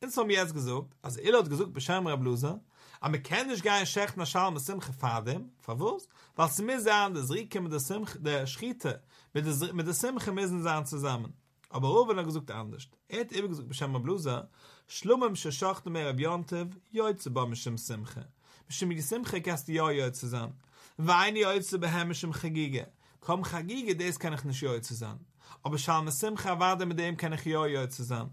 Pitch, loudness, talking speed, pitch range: 160 Hz, -32 LUFS, 190 wpm, 135-190 Hz